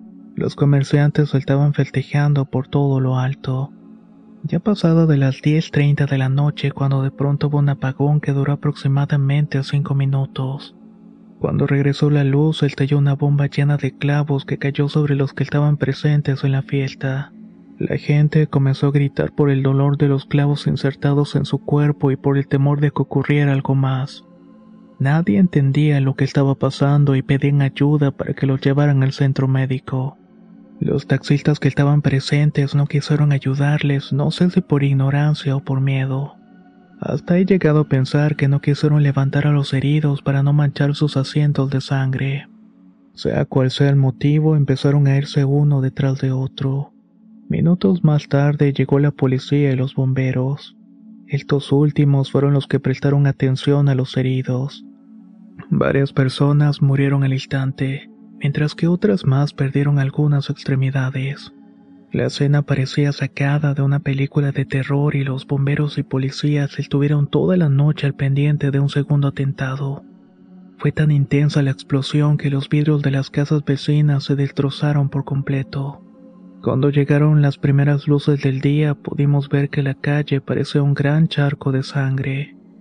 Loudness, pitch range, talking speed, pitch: -18 LUFS, 135-150 Hz, 160 wpm, 140 Hz